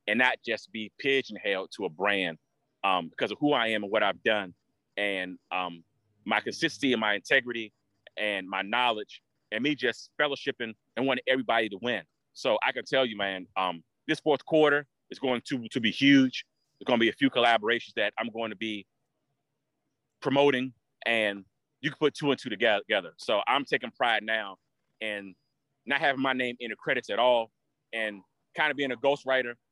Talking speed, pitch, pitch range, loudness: 190 wpm, 120 Hz, 105-140 Hz, -28 LUFS